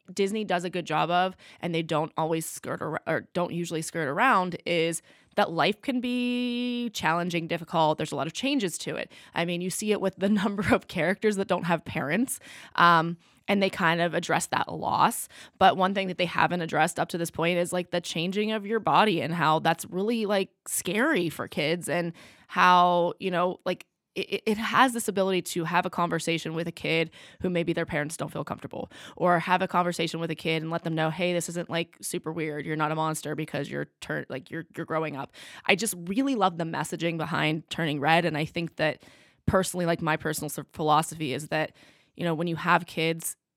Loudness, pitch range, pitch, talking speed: -27 LUFS, 160-185 Hz, 170 Hz, 215 wpm